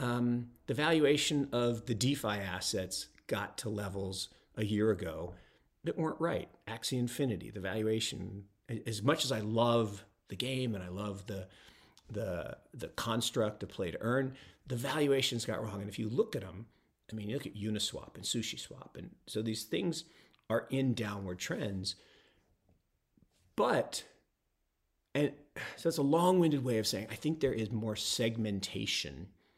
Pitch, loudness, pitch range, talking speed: 110 Hz, -35 LUFS, 105-130 Hz, 160 wpm